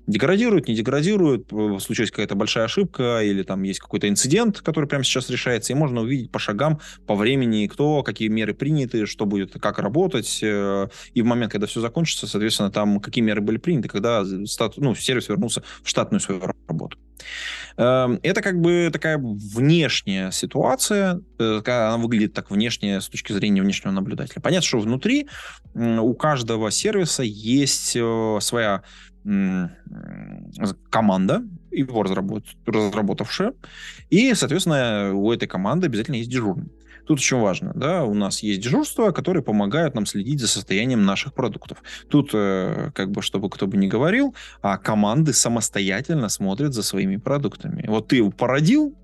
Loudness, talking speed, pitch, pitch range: -22 LUFS, 150 wpm, 120 Hz, 105-165 Hz